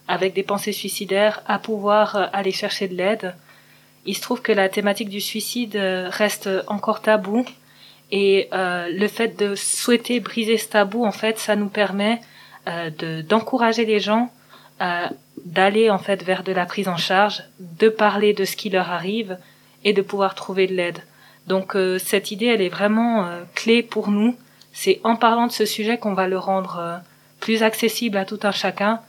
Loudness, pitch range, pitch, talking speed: -21 LUFS, 190-220 Hz, 205 Hz, 190 wpm